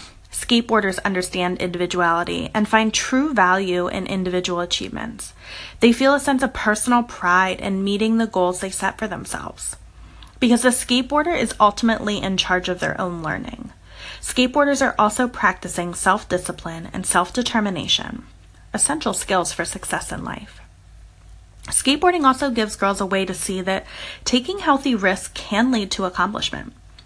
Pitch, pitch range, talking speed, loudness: 195 Hz, 180-240 Hz, 150 wpm, -20 LUFS